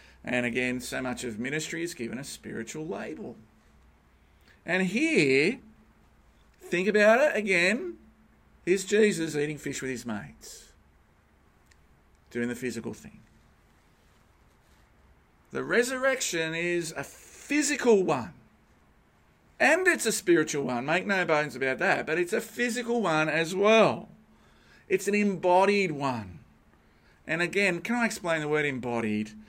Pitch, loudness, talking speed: 165 Hz, -27 LUFS, 130 wpm